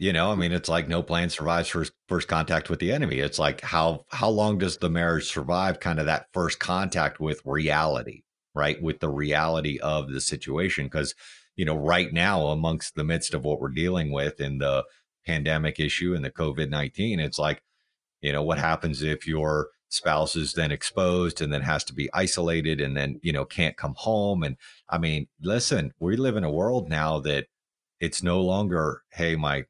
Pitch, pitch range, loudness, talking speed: 80 Hz, 75-85 Hz, -26 LUFS, 200 wpm